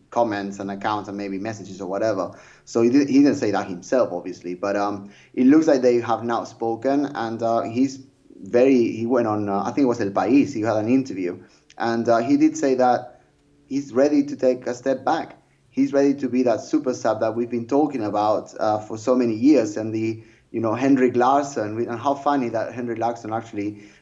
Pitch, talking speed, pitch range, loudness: 115 Hz, 215 wpm, 105-130 Hz, -22 LUFS